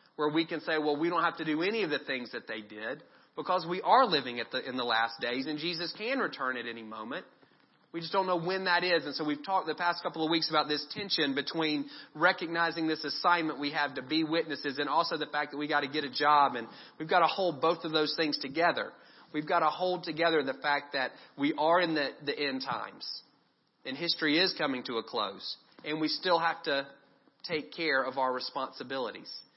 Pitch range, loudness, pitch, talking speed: 145-170 Hz, -31 LUFS, 155 Hz, 235 wpm